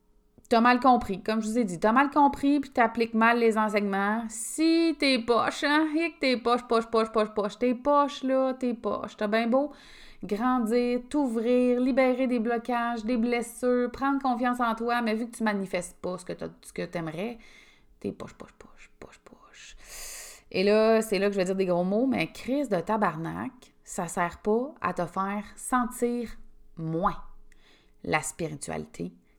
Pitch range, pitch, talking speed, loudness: 200-250 Hz, 230 Hz, 180 wpm, -27 LUFS